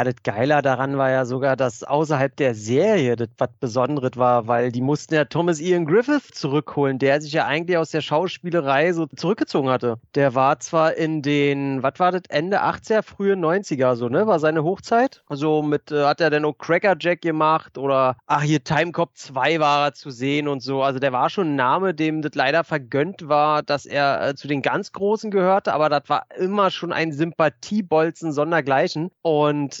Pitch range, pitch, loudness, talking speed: 135-165 Hz, 150 Hz, -21 LUFS, 200 wpm